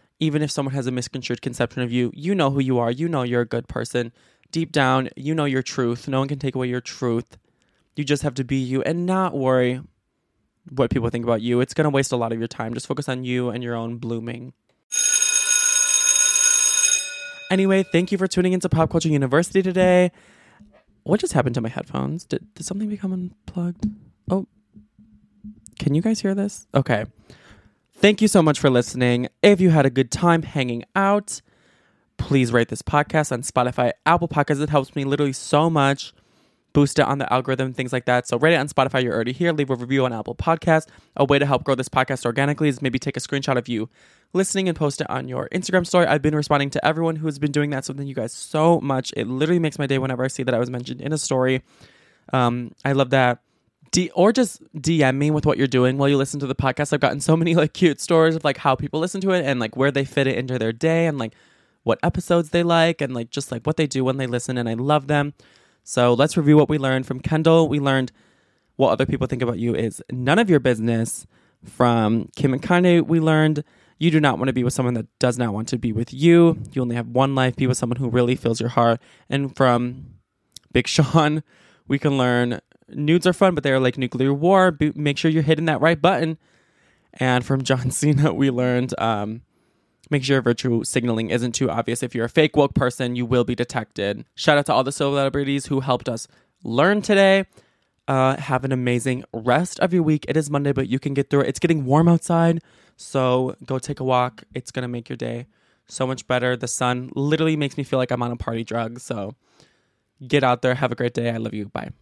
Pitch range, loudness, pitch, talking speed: 125-160 Hz, -21 LUFS, 135 Hz, 230 wpm